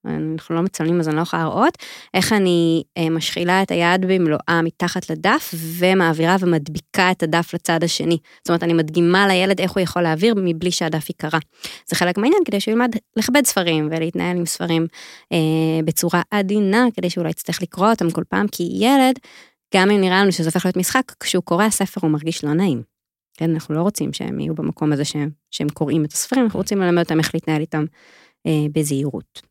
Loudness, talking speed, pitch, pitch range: -19 LUFS, 195 wpm, 170 Hz, 160-190 Hz